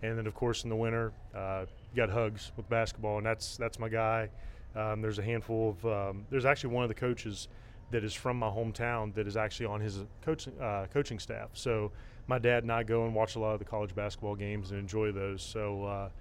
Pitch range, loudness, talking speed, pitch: 105-115 Hz, -34 LUFS, 235 wpm, 110 Hz